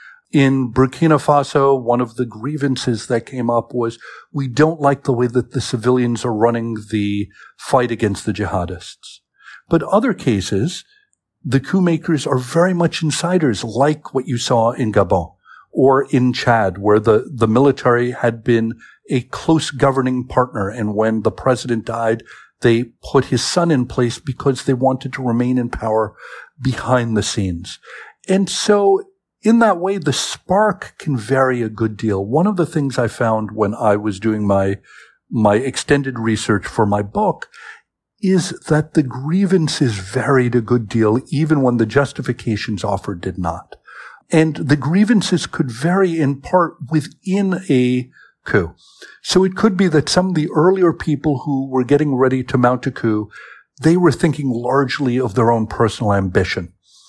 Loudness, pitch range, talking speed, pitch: -17 LUFS, 115-155 Hz, 165 wpm, 130 Hz